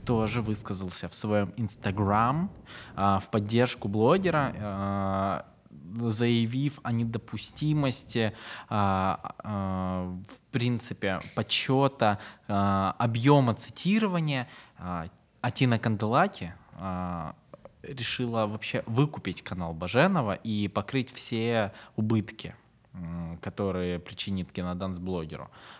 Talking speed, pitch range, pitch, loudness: 85 wpm, 95-120 Hz, 110 Hz, -29 LUFS